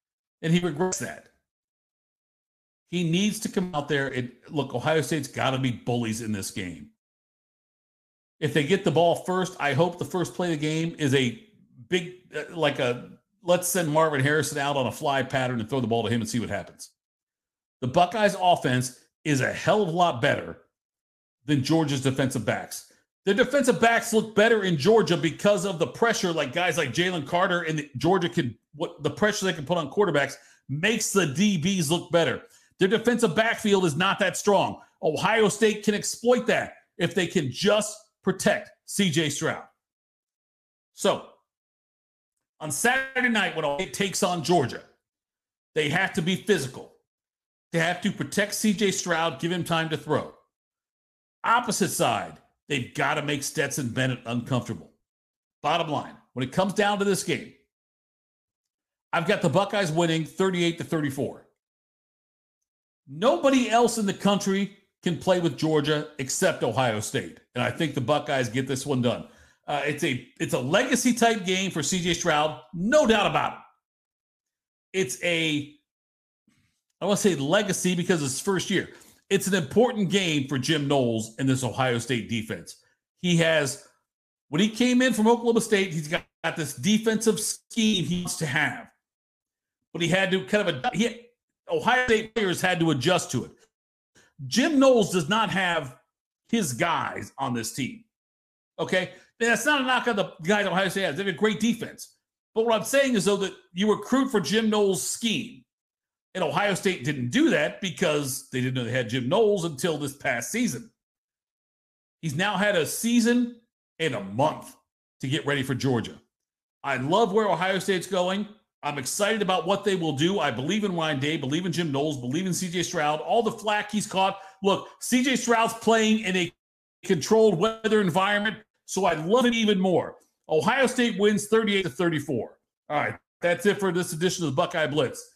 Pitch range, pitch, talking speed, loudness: 145-205 Hz, 175 Hz, 180 wpm, -25 LUFS